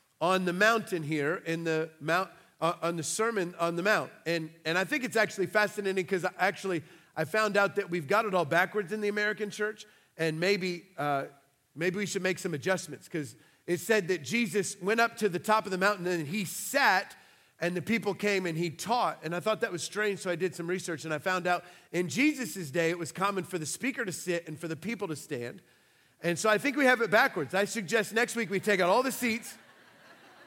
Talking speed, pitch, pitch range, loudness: 230 wpm, 185 Hz, 170-210 Hz, -30 LUFS